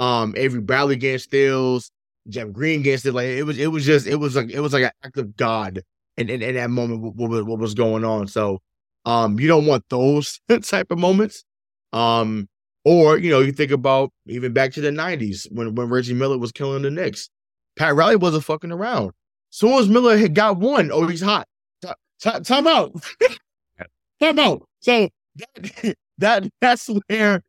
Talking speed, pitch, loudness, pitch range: 200 wpm, 135 Hz, -19 LUFS, 120-175 Hz